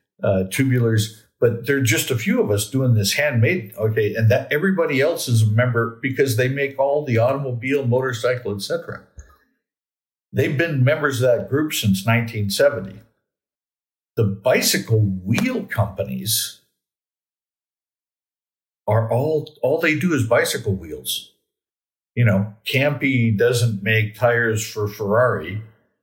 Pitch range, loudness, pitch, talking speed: 105-135 Hz, -20 LUFS, 115 Hz, 130 wpm